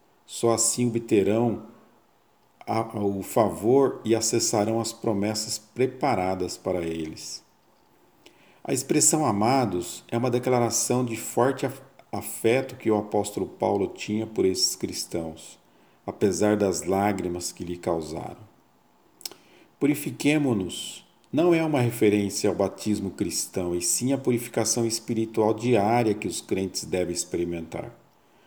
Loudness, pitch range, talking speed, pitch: -25 LUFS, 95-120 Hz, 115 wpm, 110 Hz